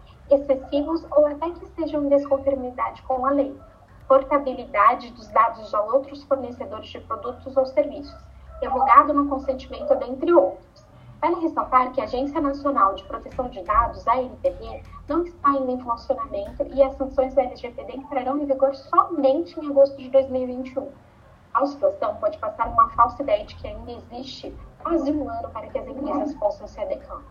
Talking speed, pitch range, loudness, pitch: 165 wpm, 260-295 Hz, -23 LUFS, 275 Hz